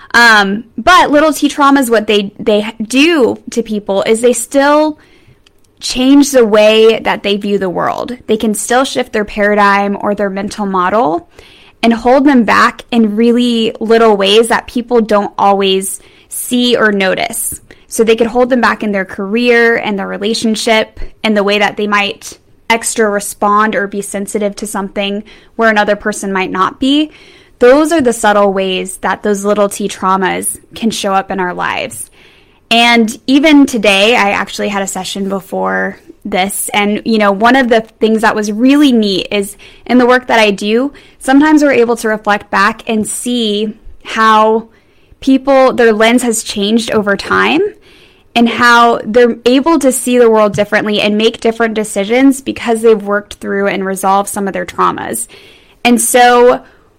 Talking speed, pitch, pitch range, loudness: 170 wpm, 220 Hz, 205-245 Hz, -11 LUFS